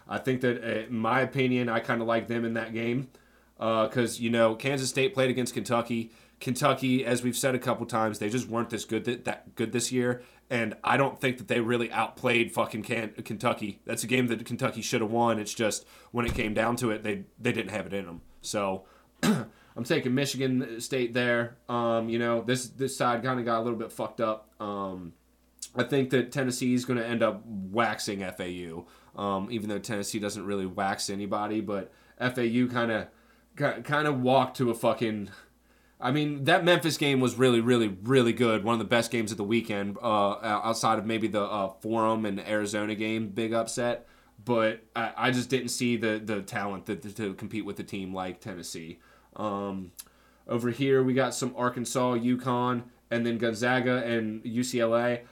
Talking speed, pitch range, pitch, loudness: 200 wpm, 110-125 Hz, 115 Hz, -29 LUFS